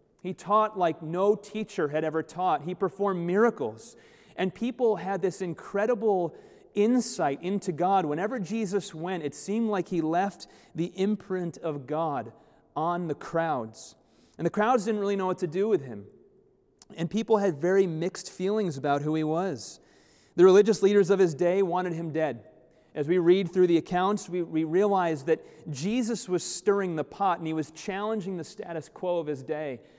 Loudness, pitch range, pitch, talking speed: -27 LUFS, 160-200 Hz, 185 Hz, 180 wpm